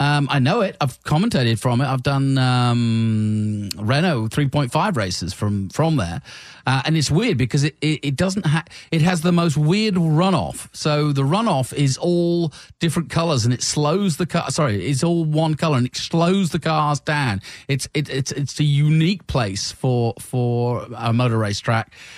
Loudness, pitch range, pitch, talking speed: -20 LUFS, 120-160 Hz, 145 Hz, 185 wpm